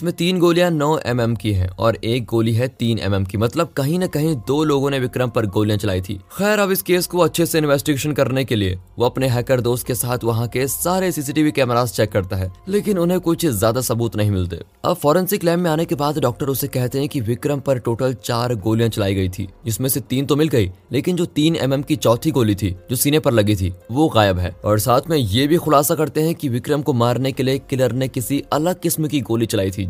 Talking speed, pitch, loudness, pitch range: 255 wpm, 130 Hz, -19 LUFS, 115-155 Hz